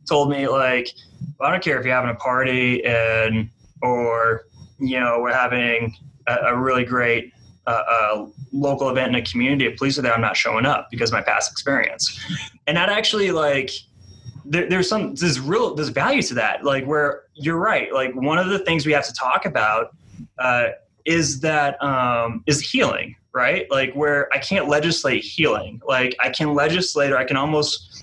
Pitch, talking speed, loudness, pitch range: 135 Hz, 190 wpm, -20 LUFS, 120-150 Hz